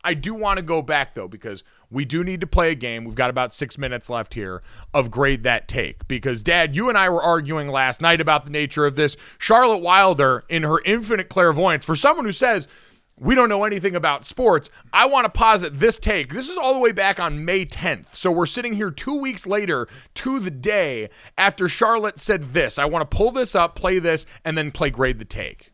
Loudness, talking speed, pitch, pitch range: -20 LUFS, 230 wpm, 170 Hz, 140-205 Hz